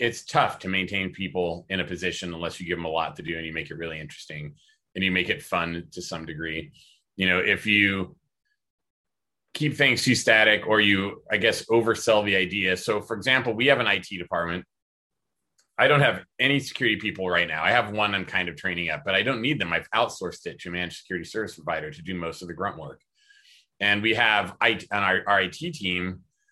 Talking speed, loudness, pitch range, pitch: 215 wpm, -24 LUFS, 90-115 Hz, 95 Hz